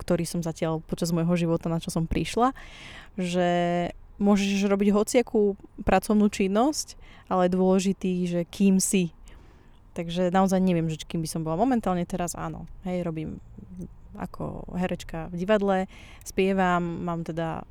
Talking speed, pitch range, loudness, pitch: 140 wpm, 170-195 Hz, -26 LUFS, 180 Hz